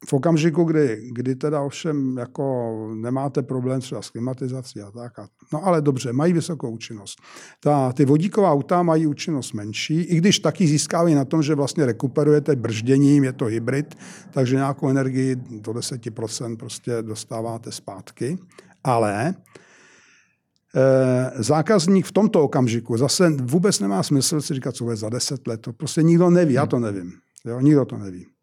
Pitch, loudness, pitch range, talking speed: 135 Hz, -21 LUFS, 120-155 Hz, 165 wpm